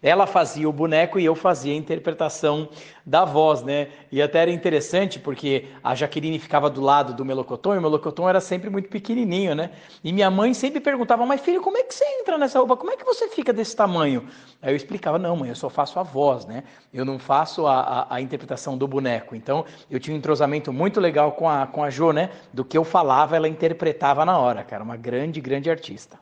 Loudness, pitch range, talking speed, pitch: -22 LUFS, 140-185 Hz, 225 wpm, 155 Hz